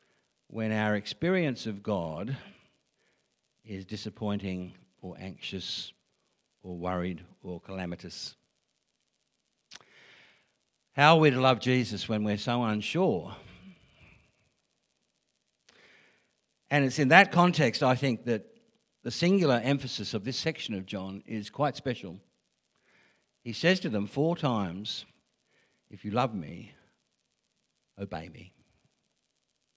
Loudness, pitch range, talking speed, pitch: -29 LUFS, 100-145 Hz, 110 wpm, 115 Hz